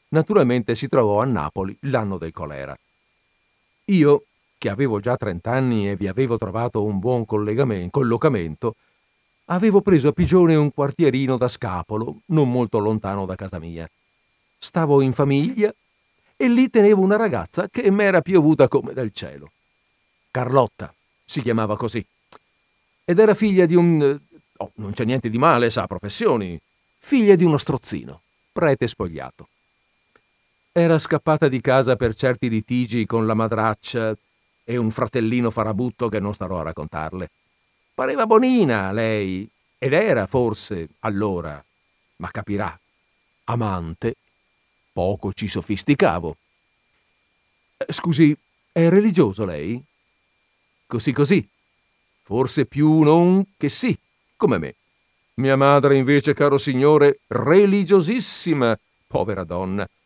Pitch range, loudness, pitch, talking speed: 105-155 Hz, -20 LUFS, 125 Hz, 125 wpm